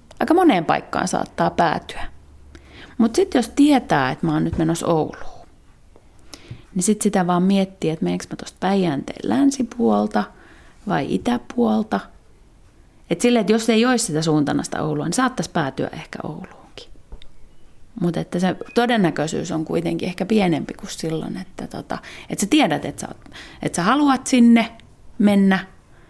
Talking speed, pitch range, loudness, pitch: 150 wpm, 150-235 Hz, -20 LUFS, 185 Hz